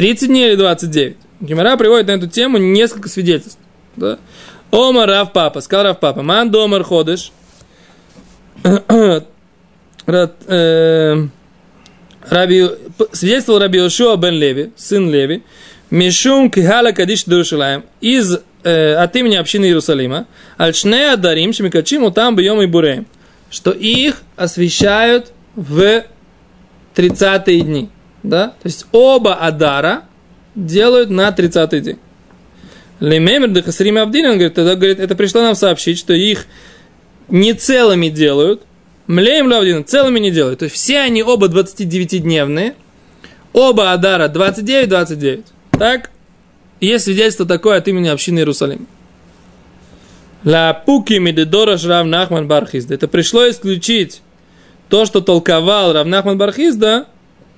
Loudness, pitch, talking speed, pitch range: -12 LUFS, 190 Hz, 115 wpm, 170-220 Hz